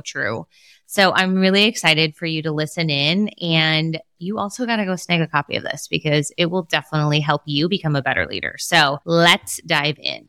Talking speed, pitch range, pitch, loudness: 205 wpm, 150-185 Hz, 160 Hz, -18 LUFS